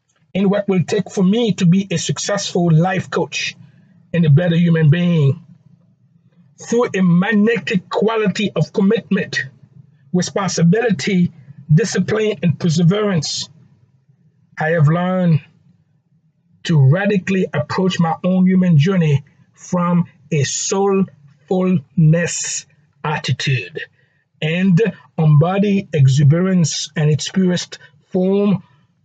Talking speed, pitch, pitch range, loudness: 100 wpm, 165 Hz, 150-190 Hz, -16 LUFS